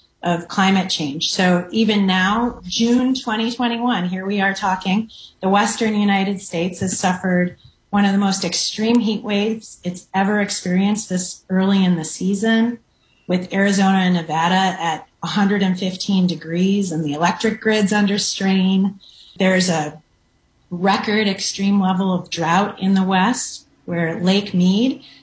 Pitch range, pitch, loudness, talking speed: 180-205 Hz, 195 Hz, -18 LUFS, 140 wpm